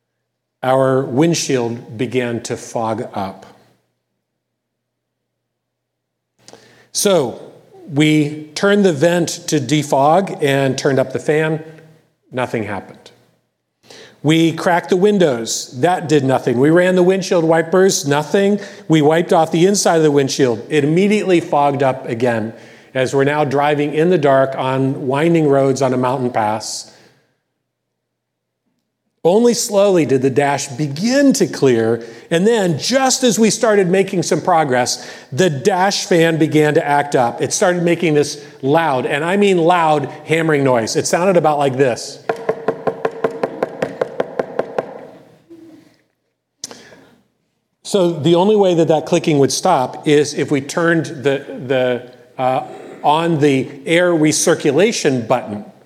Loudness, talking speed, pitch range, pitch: -15 LUFS, 130 wpm, 130-175 Hz, 150 Hz